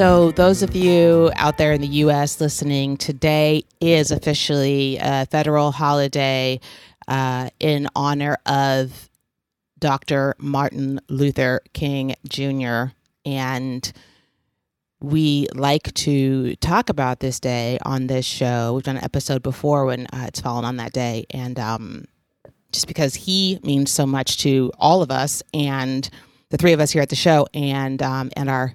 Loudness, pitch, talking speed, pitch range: -20 LUFS, 140 Hz, 150 wpm, 130-150 Hz